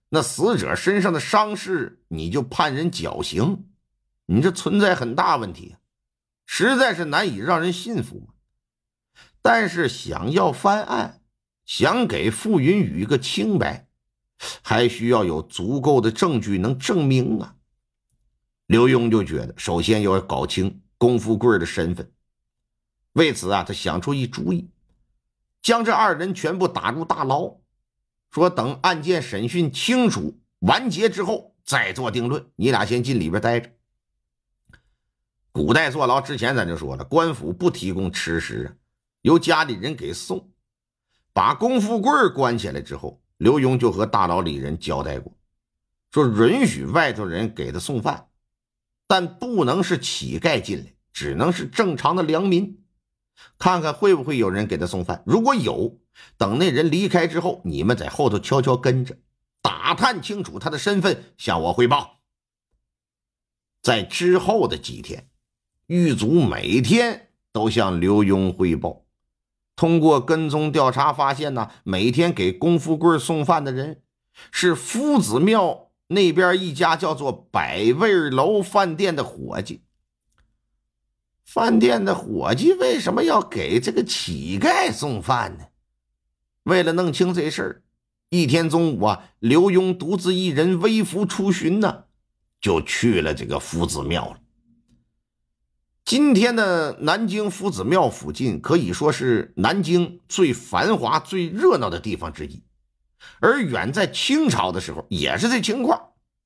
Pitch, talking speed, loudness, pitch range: 155 Hz, 210 characters per minute, -21 LUFS, 110-185 Hz